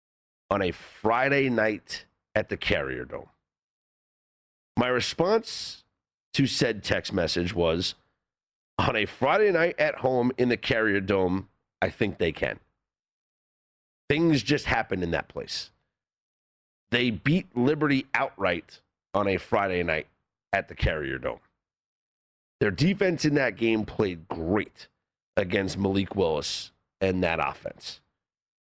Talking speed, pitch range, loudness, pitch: 125 wpm, 90-135 Hz, -27 LUFS, 110 Hz